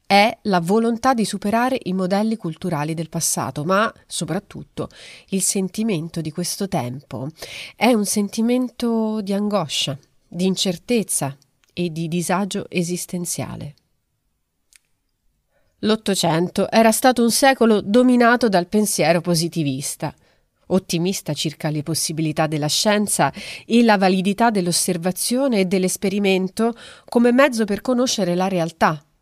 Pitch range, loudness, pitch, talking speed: 170-220 Hz, -19 LUFS, 190 Hz, 115 wpm